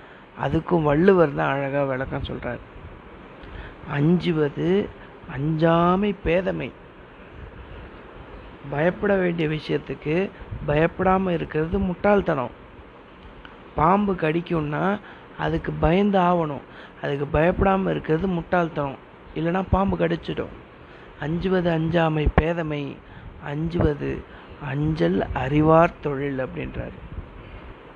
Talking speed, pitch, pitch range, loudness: 75 wpm, 160 Hz, 145-180 Hz, -23 LUFS